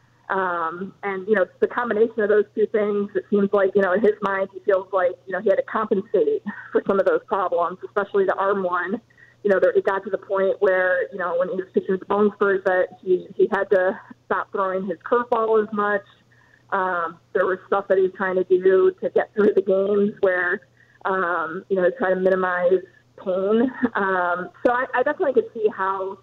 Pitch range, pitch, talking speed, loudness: 185-210 Hz, 195 Hz, 220 wpm, -22 LUFS